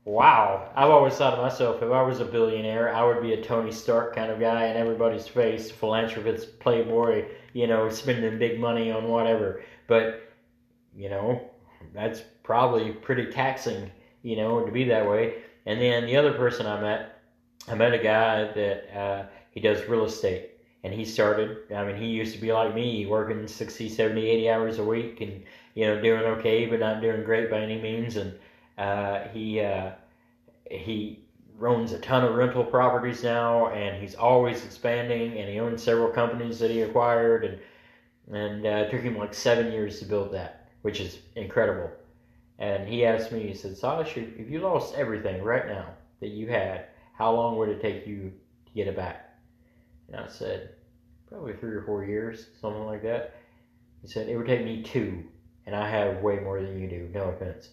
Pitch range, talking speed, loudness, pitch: 105-120 Hz, 190 wpm, -26 LUFS, 115 Hz